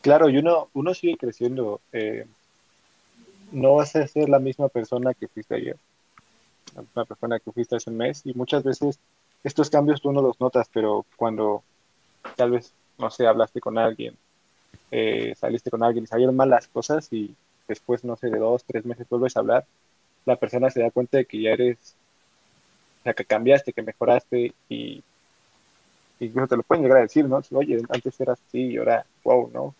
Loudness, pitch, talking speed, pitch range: -23 LUFS, 125 Hz, 195 wpm, 115-135 Hz